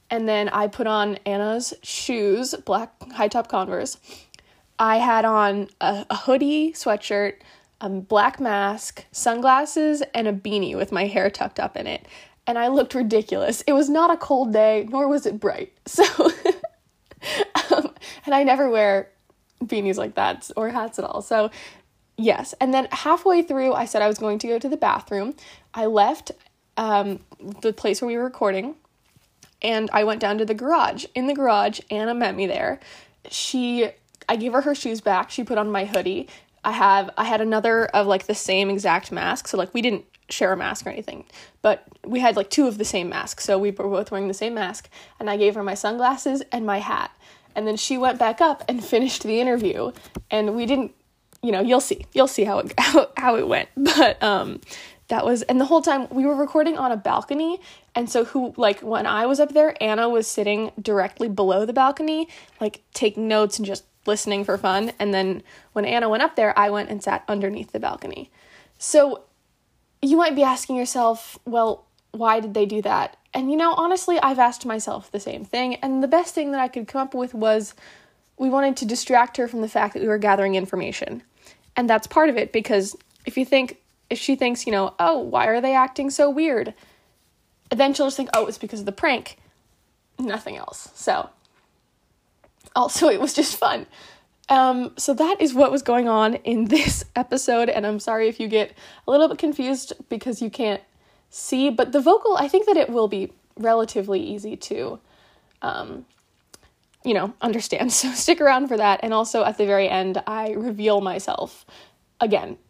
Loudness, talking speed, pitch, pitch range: -22 LUFS, 200 wpm, 230 Hz, 210-270 Hz